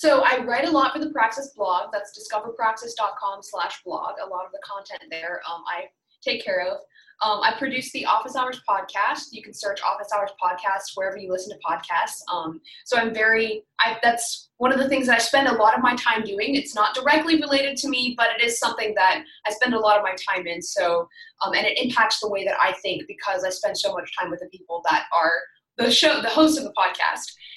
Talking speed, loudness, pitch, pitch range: 235 wpm, -22 LUFS, 225 Hz, 200-270 Hz